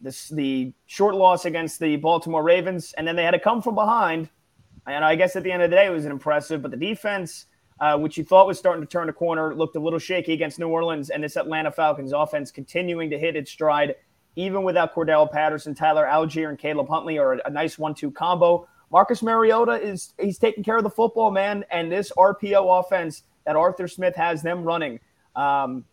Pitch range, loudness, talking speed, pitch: 150-185 Hz, -22 LUFS, 220 wpm, 165 Hz